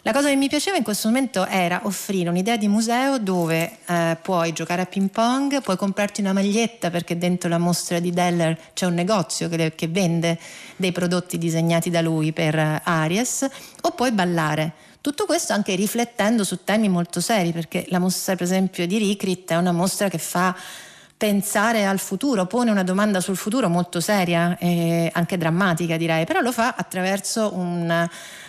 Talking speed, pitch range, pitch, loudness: 180 wpm, 170-210 Hz, 185 Hz, -22 LUFS